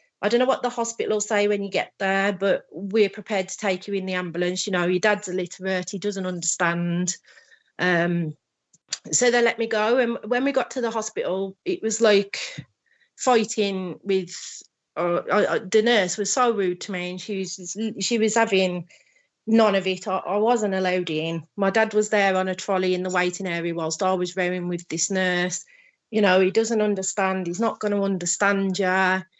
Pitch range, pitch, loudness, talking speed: 185-220 Hz, 195 Hz, -23 LUFS, 200 wpm